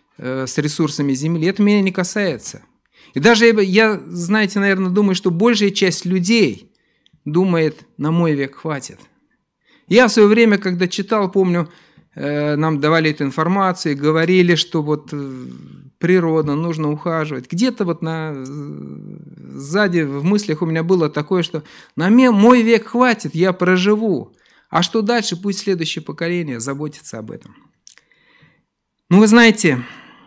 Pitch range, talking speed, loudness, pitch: 155-200 Hz, 135 wpm, -16 LUFS, 175 Hz